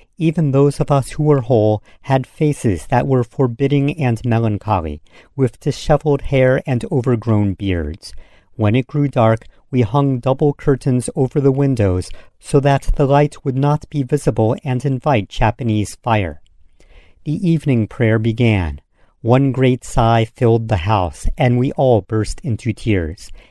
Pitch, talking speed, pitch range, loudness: 125 Hz, 150 wpm, 105-140 Hz, -17 LUFS